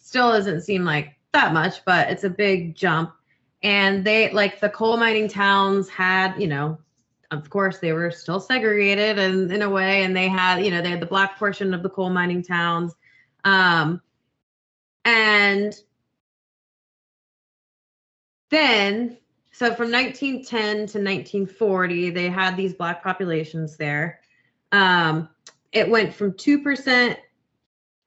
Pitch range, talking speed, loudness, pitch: 170-210 Hz, 140 wpm, -20 LUFS, 195 Hz